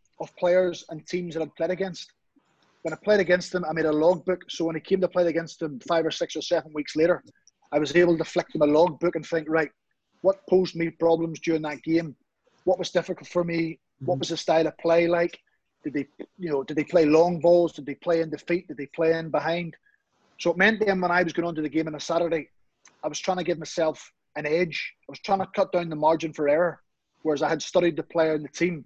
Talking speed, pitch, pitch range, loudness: 260 wpm, 165 Hz, 155-175 Hz, -25 LUFS